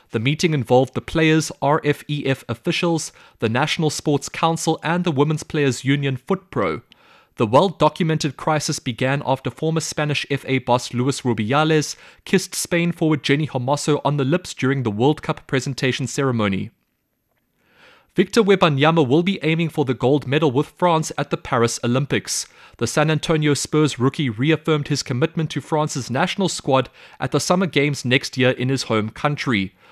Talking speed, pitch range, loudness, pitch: 160 wpm, 130-160 Hz, -20 LUFS, 145 Hz